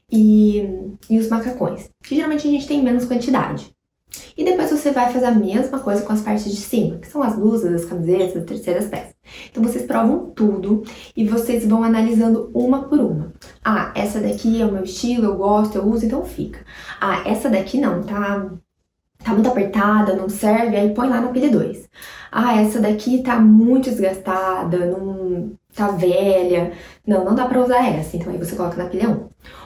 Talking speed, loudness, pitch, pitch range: 195 wpm, -18 LUFS, 215 Hz, 195-245 Hz